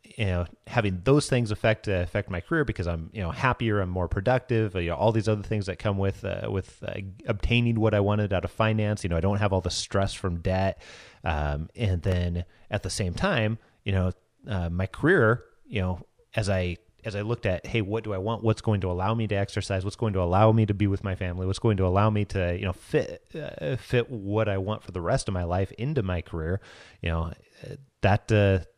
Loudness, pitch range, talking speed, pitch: -27 LUFS, 95-110 Hz, 240 wpm, 100 Hz